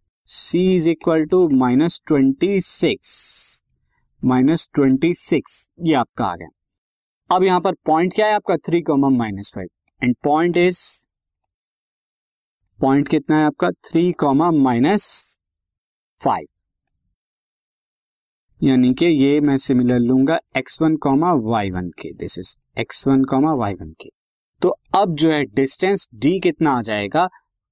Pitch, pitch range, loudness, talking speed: 150 Hz, 130-175 Hz, -17 LUFS, 140 wpm